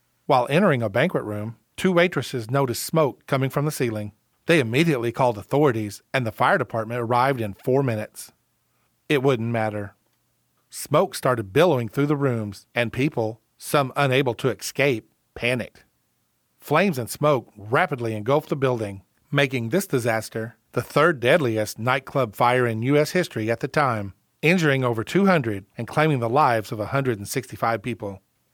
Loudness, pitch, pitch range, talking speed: -23 LUFS, 125 Hz, 110-145 Hz, 150 wpm